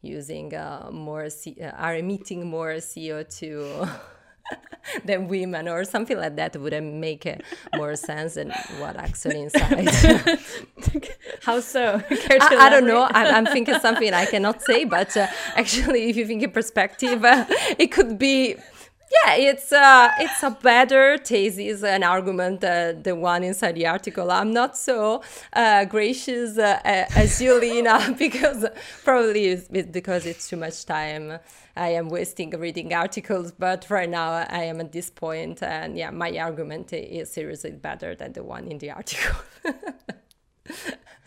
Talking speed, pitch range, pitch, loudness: 155 wpm, 170-250 Hz, 200 Hz, -20 LUFS